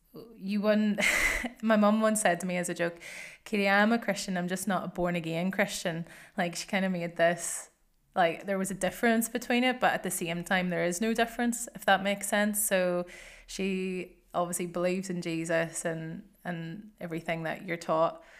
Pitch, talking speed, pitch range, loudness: 185 Hz, 195 wpm, 175-205 Hz, -29 LUFS